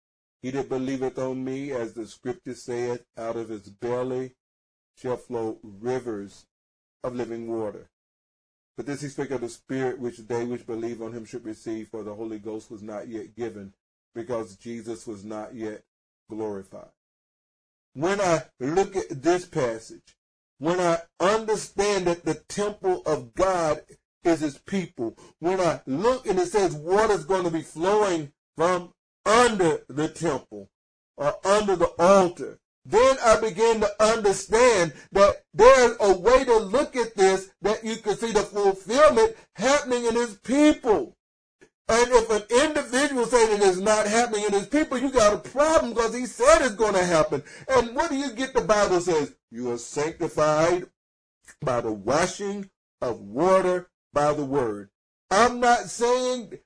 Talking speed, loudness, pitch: 160 wpm, -24 LUFS, 175 Hz